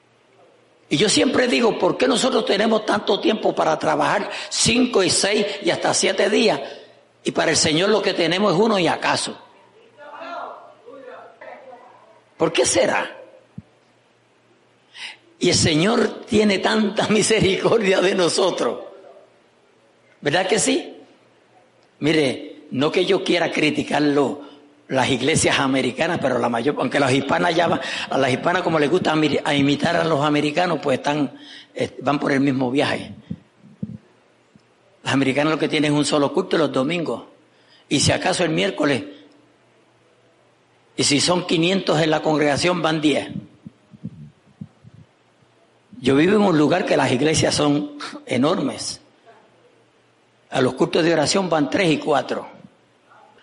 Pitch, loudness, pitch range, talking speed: 160 Hz, -19 LUFS, 145-195 Hz, 140 wpm